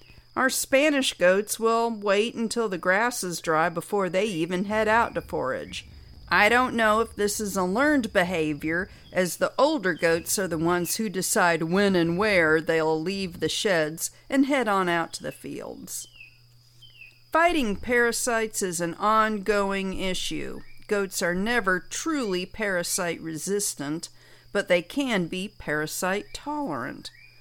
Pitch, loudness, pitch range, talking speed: 190 Hz, -25 LUFS, 170-225 Hz, 145 wpm